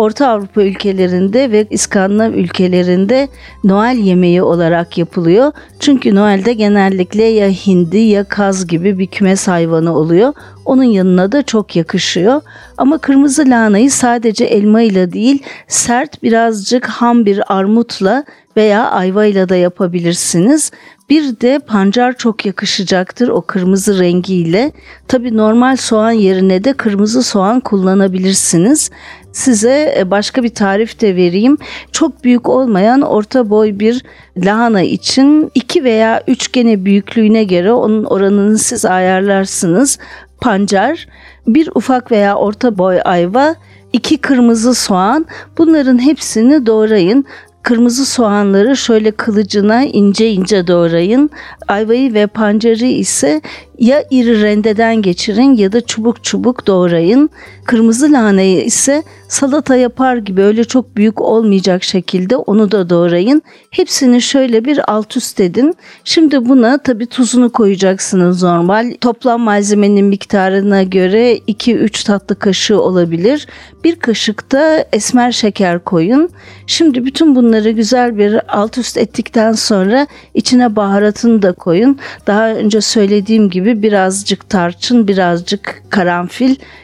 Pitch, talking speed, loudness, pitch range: 220 Hz, 120 wpm, -11 LUFS, 195-250 Hz